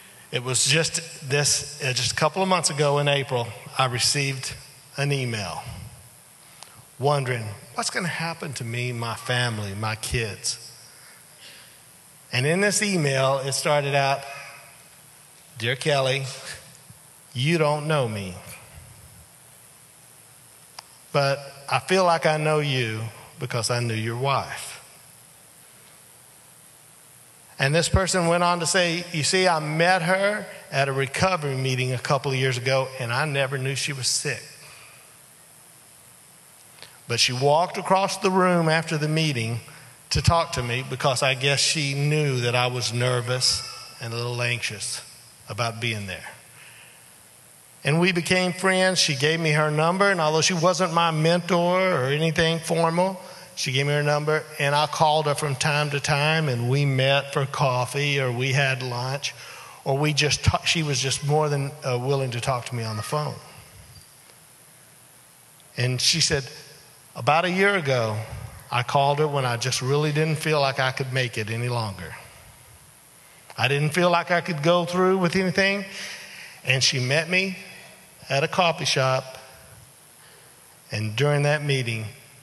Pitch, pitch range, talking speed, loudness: 140 Hz, 125-160 Hz, 155 wpm, -23 LUFS